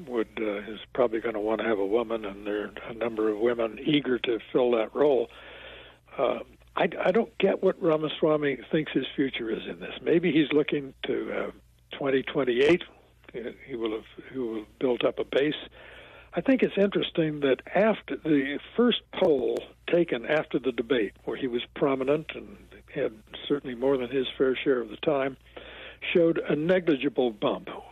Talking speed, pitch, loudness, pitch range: 180 wpm, 135 Hz, -27 LUFS, 115-165 Hz